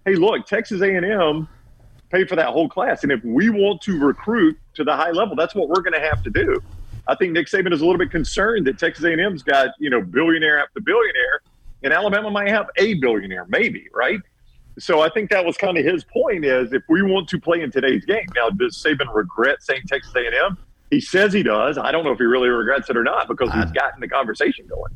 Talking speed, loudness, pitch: 235 wpm, -19 LUFS, 205 Hz